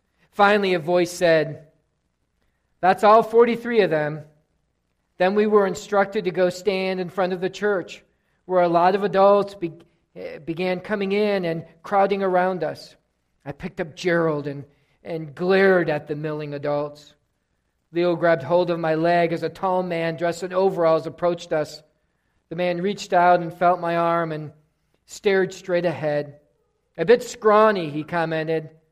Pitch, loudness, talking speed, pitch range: 170 Hz, -21 LUFS, 160 wpm, 155-190 Hz